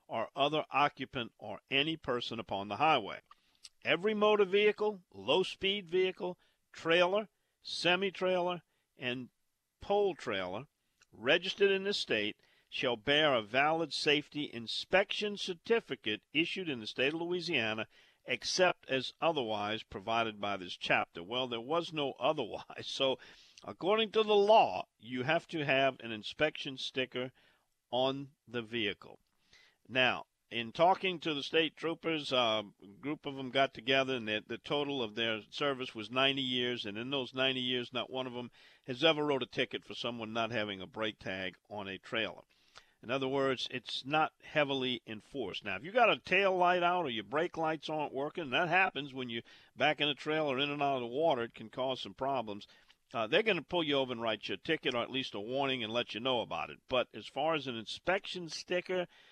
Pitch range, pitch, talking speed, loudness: 120-170 Hz, 135 Hz, 185 wpm, -33 LUFS